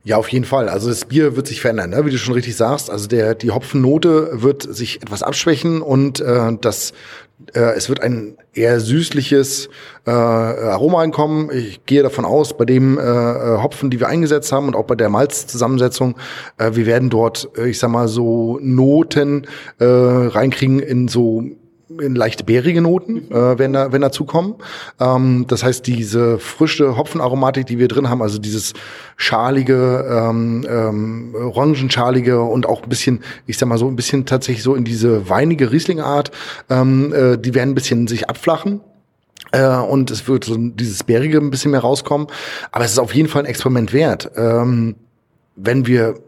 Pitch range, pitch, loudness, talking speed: 115-140 Hz, 125 Hz, -16 LUFS, 180 wpm